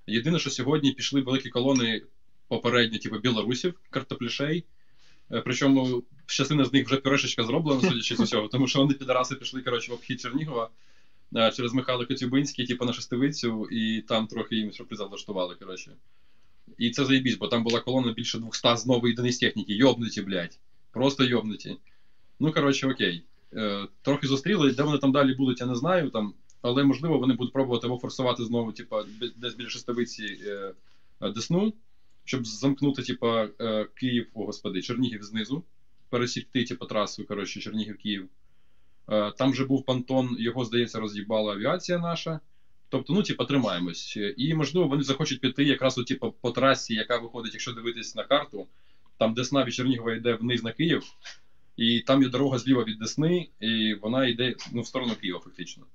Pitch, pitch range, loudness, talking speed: 125 Hz, 115-135 Hz, -27 LUFS, 160 wpm